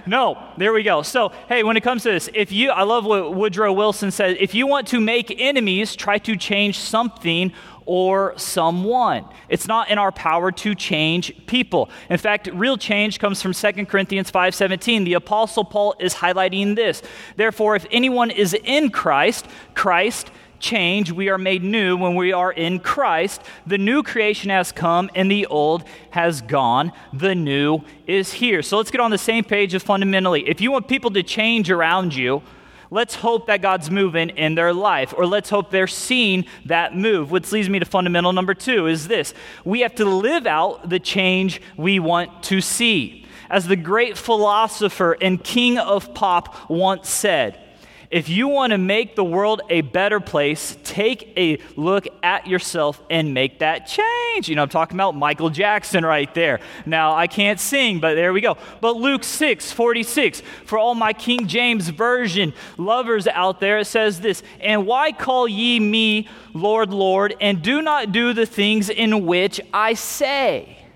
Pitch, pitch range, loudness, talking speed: 200 Hz, 180-225 Hz, -19 LUFS, 185 wpm